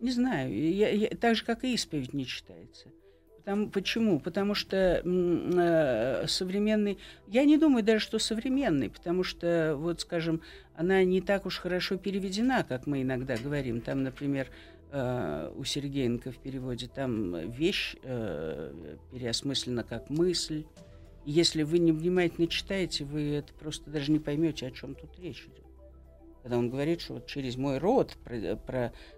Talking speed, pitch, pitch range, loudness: 160 wpm, 160 Hz, 130-195 Hz, -30 LUFS